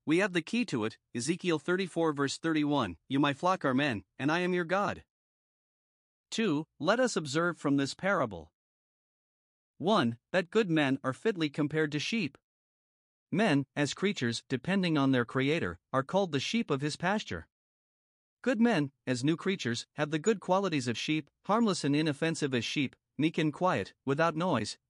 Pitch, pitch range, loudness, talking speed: 155 Hz, 135-185 Hz, -31 LUFS, 170 wpm